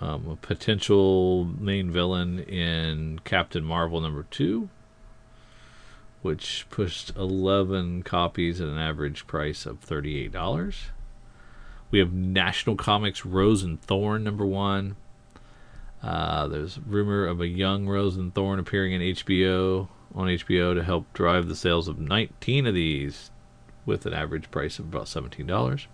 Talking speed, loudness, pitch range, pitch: 135 wpm, -26 LUFS, 85-100 Hz, 95 Hz